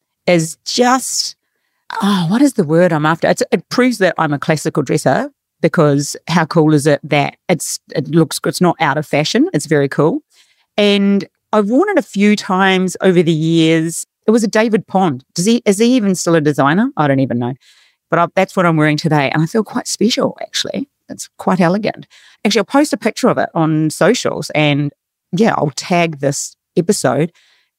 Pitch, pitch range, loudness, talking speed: 170 Hz, 155-215 Hz, -15 LUFS, 200 wpm